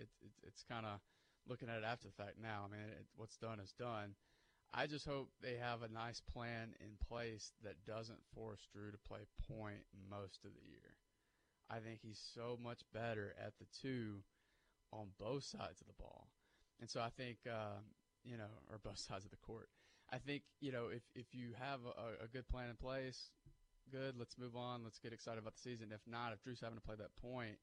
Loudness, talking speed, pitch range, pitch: -51 LUFS, 220 wpm, 105-120 Hz, 115 Hz